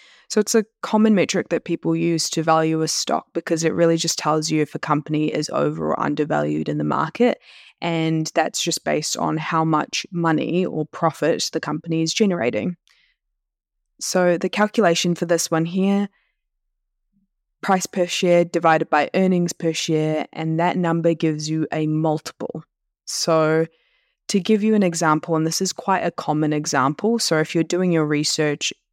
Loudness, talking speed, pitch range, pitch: -21 LUFS, 170 wpm, 155-180 Hz, 165 Hz